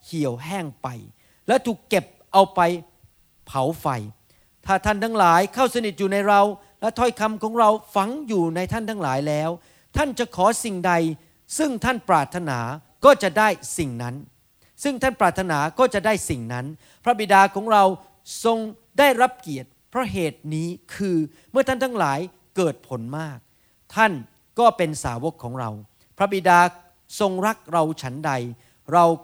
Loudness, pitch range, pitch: -22 LUFS, 145-215 Hz, 180 Hz